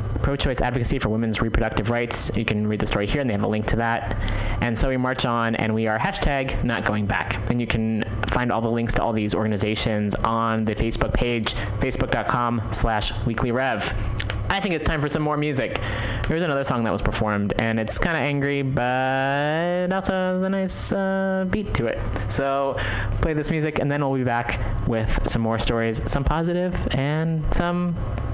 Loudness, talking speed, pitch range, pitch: -23 LUFS, 200 wpm, 110-140 Hz, 115 Hz